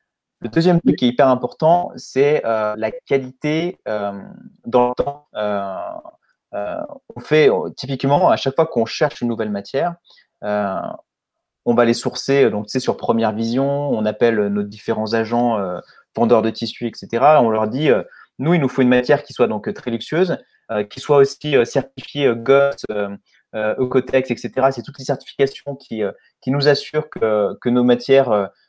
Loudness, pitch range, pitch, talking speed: -18 LUFS, 110-140 Hz, 125 Hz, 190 wpm